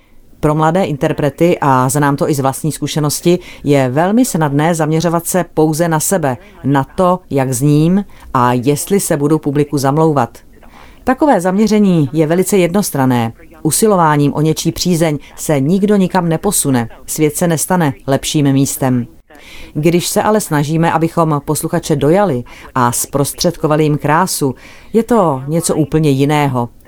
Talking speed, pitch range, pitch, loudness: 140 wpm, 140-175 Hz, 155 Hz, -13 LUFS